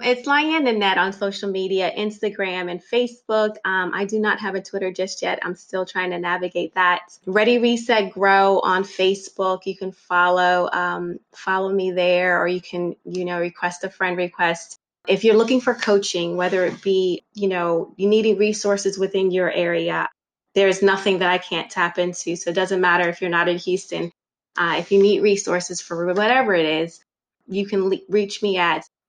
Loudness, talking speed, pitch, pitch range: -20 LUFS, 190 wpm, 190 Hz, 180-200 Hz